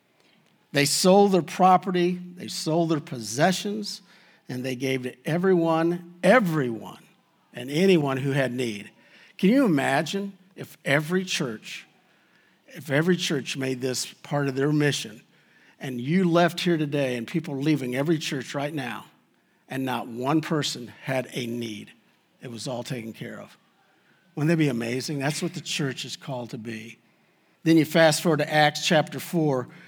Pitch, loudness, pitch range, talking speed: 150 Hz, -24 LUFS, 130-175 Hz, 160 wpm